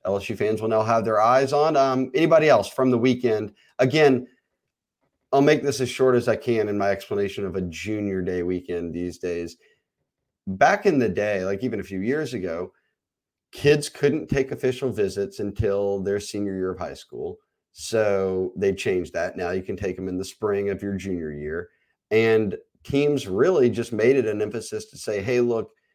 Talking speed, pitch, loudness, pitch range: 190 wpm, 110 Hz, -23 LUFS, 100-130 Hz